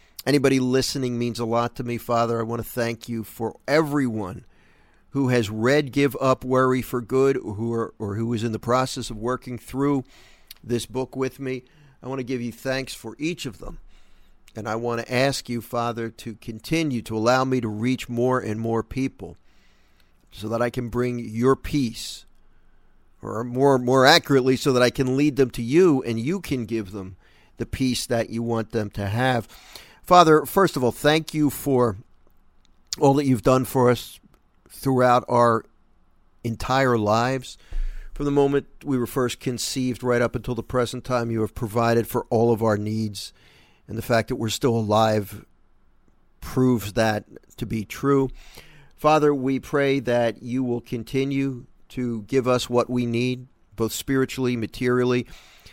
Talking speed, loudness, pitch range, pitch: 180 wpm, -23 LUFS, 115-130 Hz, 120 Hz